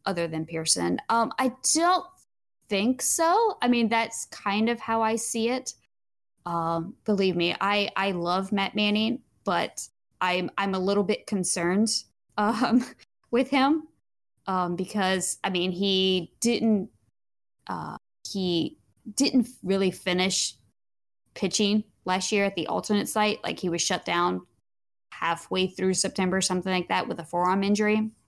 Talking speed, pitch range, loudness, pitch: 145 wpm, 180-225 Hz, -26 LUFS, 195 Hz